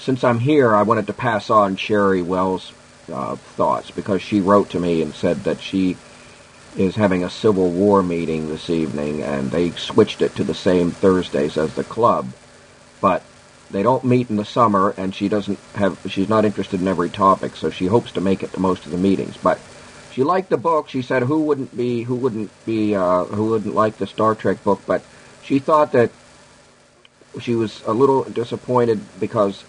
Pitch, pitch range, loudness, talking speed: 100 Hz, 90-115 Hz, -19 LUFS, 200 wpm